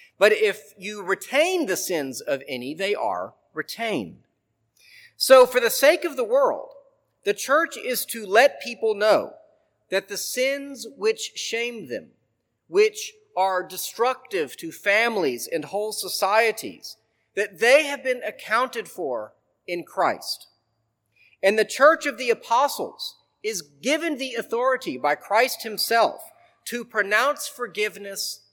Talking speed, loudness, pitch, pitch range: 135 wpm, -23 LUFS, 240 Hz, 205-315 Hz